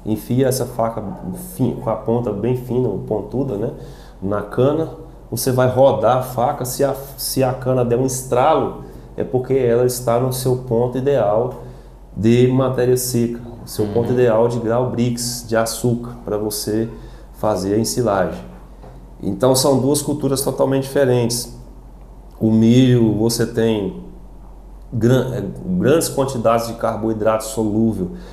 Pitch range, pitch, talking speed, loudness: 110-130 Hz, 120 Hz, 140 wpm, -18 LUFS